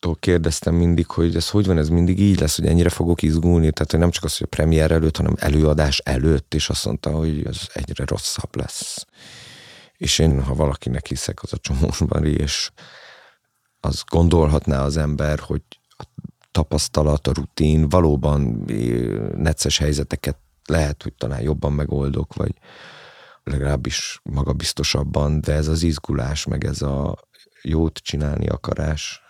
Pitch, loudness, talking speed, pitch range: 75 Hz, -21 LUFS, 150 wpm, 70-85 Hz